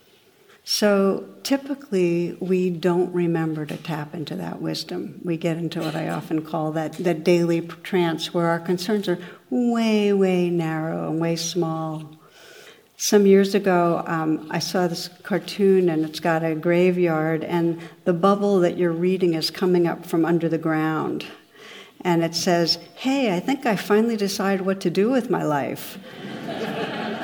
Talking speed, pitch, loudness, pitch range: 160 wpm, 175 Hz, -22 LUFS, 165-195 Hz